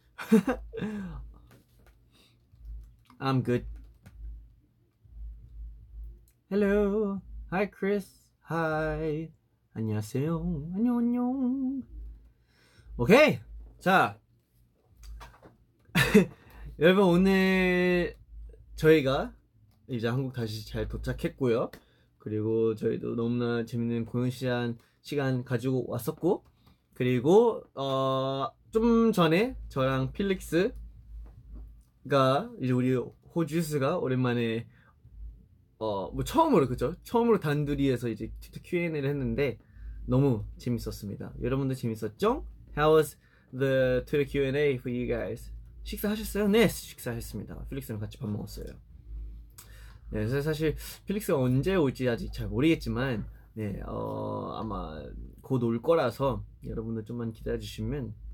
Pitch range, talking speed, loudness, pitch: 110-160 Hz, 245 characters per minute, -29 LUFS, 125 Hz